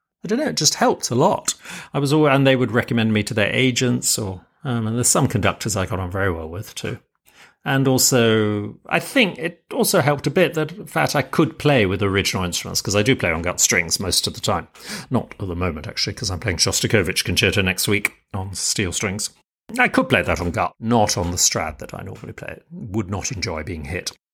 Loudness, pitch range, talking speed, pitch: -20 LUFS, 95-135 Hz, 235 wpm, 110 Hz